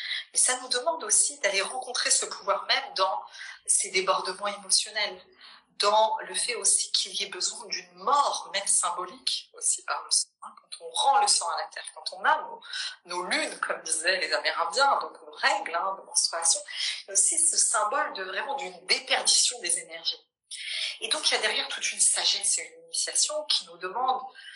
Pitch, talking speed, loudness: 280 Hz, 195 wpm, -25 LUFS